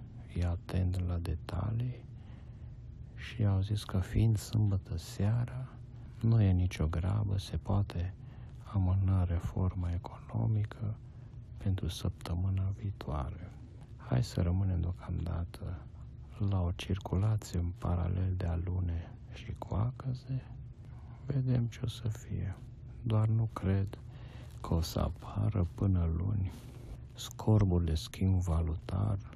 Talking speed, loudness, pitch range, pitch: 110 wpm, -34 LUFS, 90-115 Hz, 105 Hz